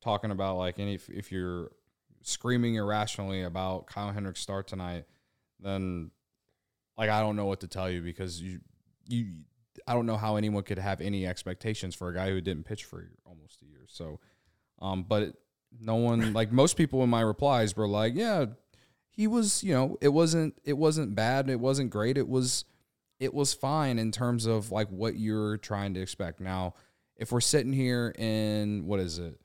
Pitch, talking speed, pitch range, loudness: 105 Hz, 190 wpm, 95-125 Hz, -30 LUFS